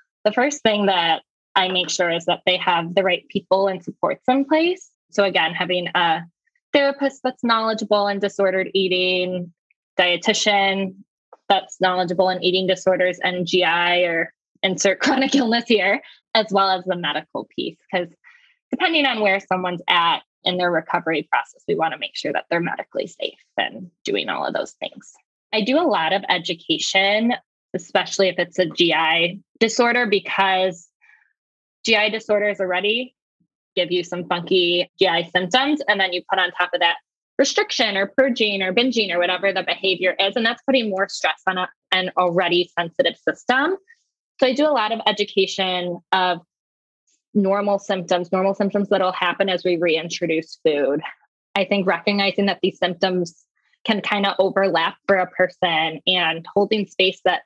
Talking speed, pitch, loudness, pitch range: 165 wpm, 190 Hz, -20 LUFS, 180-215 Hz